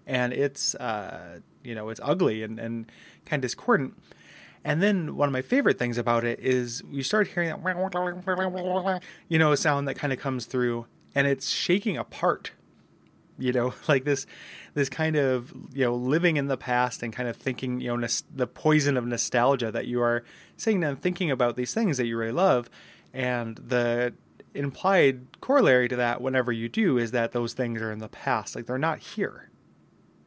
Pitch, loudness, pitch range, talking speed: 130 Hz, -27 LUFS, 120-150 Hz, 190 wpm